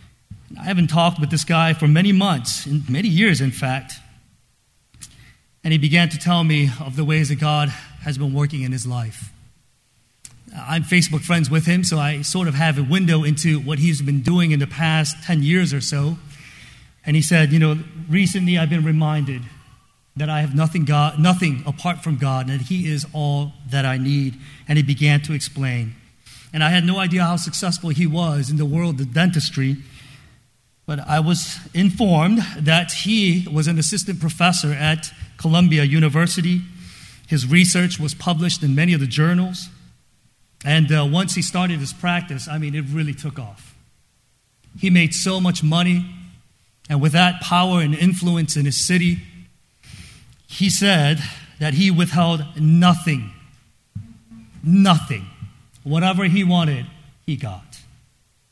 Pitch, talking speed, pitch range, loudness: 155 Hz, 165 wpm, 135-170 Hz, -19 LUFS